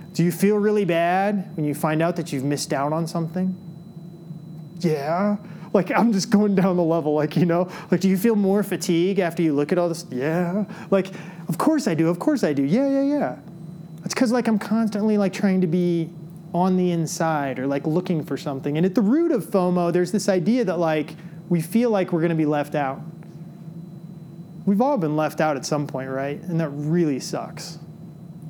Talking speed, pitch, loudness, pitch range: 215 wpm, 170 Hz, -22 LUFS, 160-195 Hz